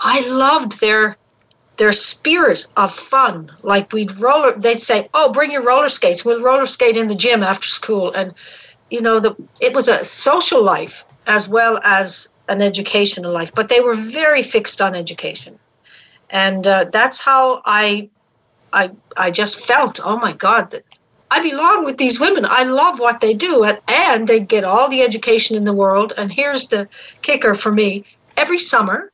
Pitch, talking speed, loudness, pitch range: 225 Hz, 180 wpm, -14 LUFS, 205-260 Hz